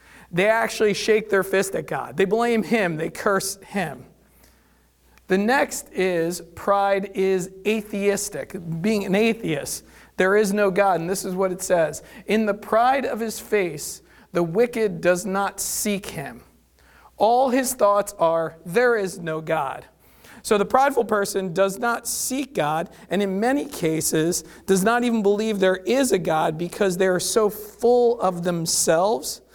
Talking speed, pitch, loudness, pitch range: 160 wpm, 200 Hz, -22 LUFS, 185-220 Hz